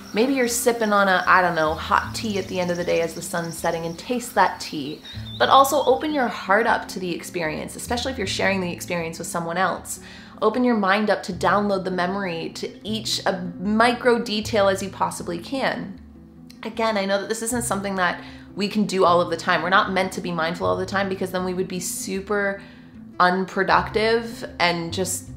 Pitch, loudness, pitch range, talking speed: 190 Hz, -22 LUFS, 175-220 Hz, 220 wpm